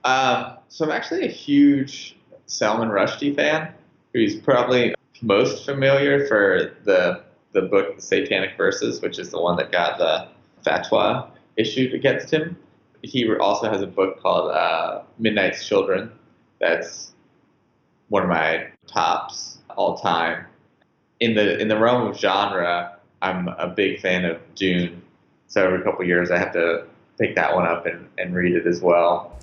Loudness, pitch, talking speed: -21 LUFS, 125 Hz, 160 wpm